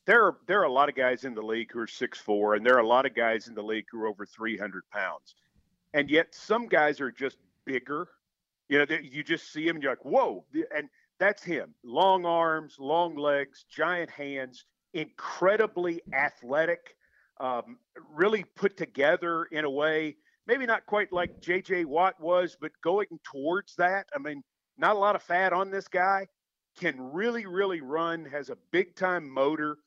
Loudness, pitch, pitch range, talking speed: -28 LUFS, 165 Hz, 140-185 Hz, 190 wpm